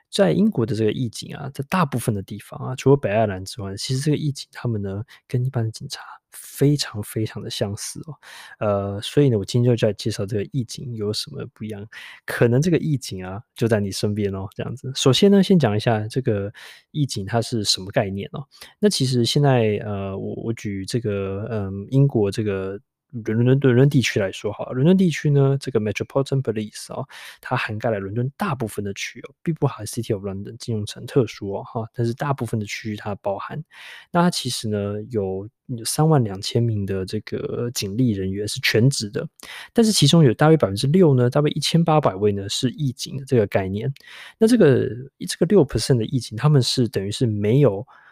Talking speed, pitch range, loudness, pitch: 340 characters per minute, 105-140 Hz, -21 LUFS, 120 Hz